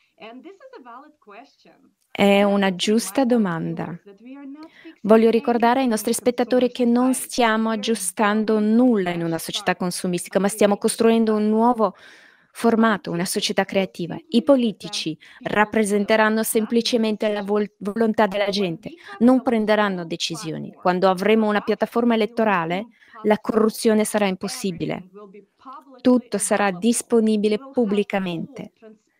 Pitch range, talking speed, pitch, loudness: 200-235 Hz, 105 wpm, 215 Hz, -20 LUFS